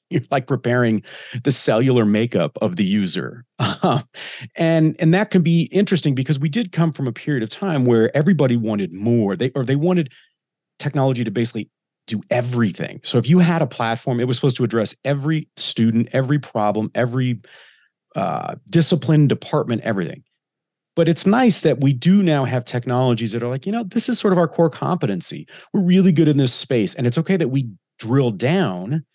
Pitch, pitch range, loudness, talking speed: 140 Hz, 120-165 Hz, -19 LUFS, 185 wpm